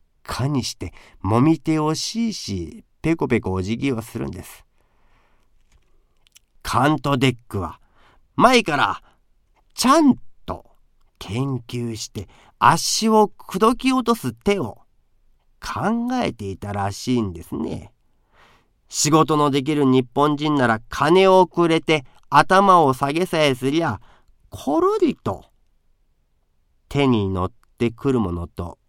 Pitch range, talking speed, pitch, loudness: 105-160 Hz, 215 characters per minute, 130 Hz, -20 LUFS